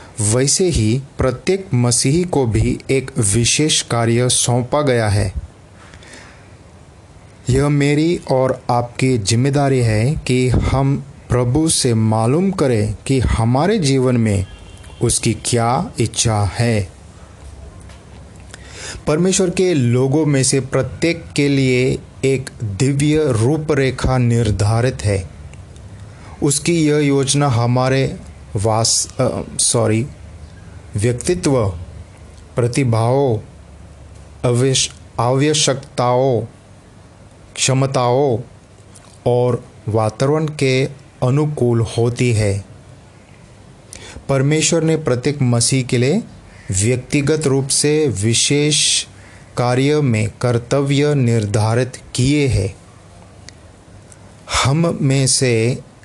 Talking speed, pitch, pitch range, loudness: 85 wpm, 120 Hz, 105-135 Hz, -16 LUFS